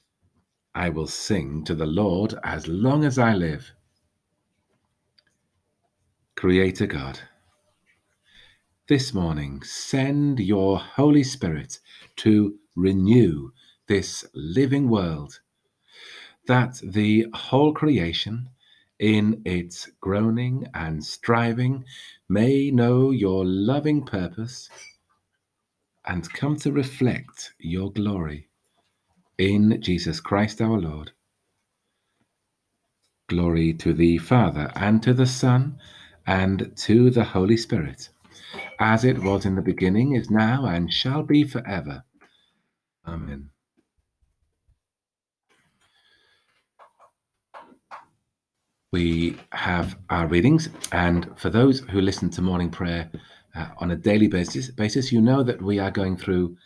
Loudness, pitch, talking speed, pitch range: -23 LUFS, 100 Hz, 105 wpm, 85-125 Hz